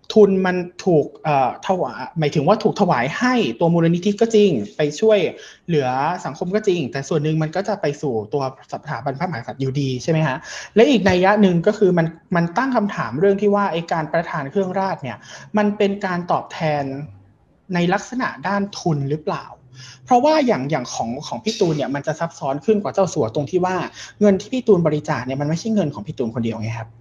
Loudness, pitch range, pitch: -20 LUFS, 145-200 Hz, 170 Hz